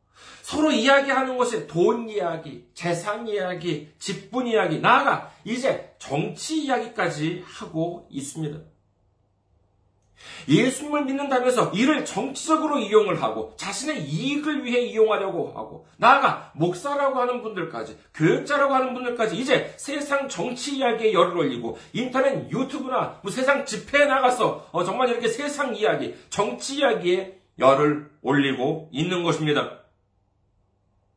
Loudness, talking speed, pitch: -23 LUFS, 310 characters per minute, 210 Hz